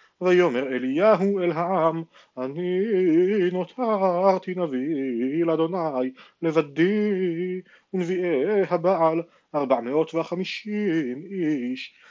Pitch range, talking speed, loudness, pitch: 160-190 Hz, 75 wpm, -24 LUFS, 180 Hz